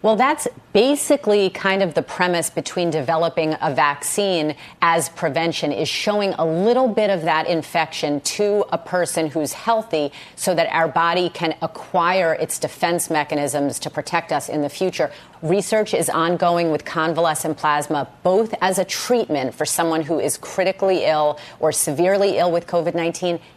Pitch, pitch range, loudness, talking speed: 165 Hz, 155-185 Hz, -20 LUFS, 160 wpm